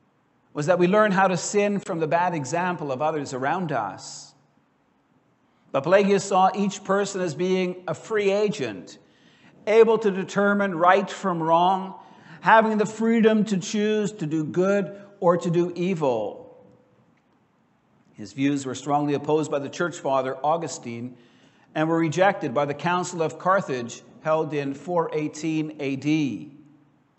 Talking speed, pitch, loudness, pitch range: 145 wpm, 175 Hz, -23 LUFS, 150-195 Hz